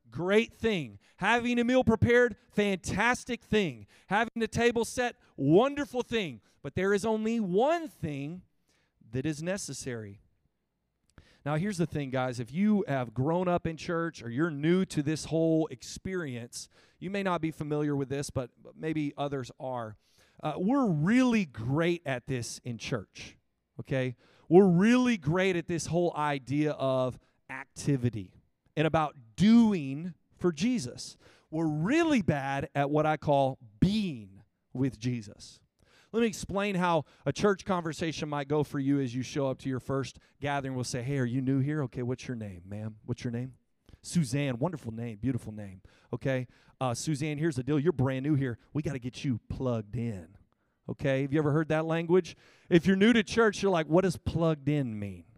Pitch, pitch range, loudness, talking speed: 150 Hz, 130-180 Hz, -30 LUFS, 175 wpm